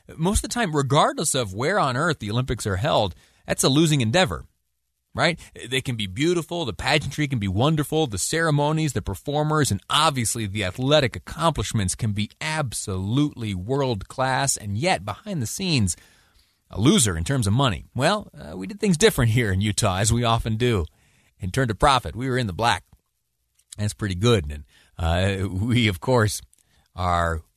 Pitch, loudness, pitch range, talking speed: 115 Hz, -23 LUFS, 95-145 Hz, 180 wpm